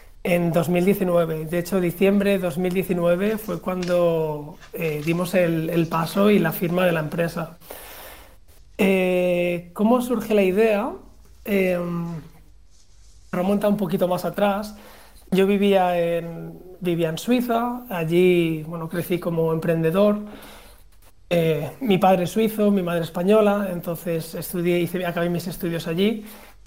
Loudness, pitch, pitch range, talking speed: -22 LUFS, 175 Hz, 165-195 Hz, 130 wpm